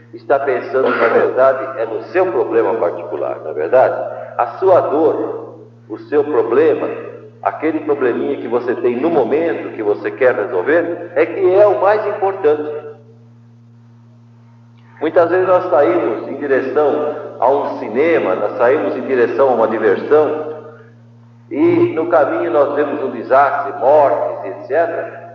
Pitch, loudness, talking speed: 175 Hz, -15 LUFS, 140 wpm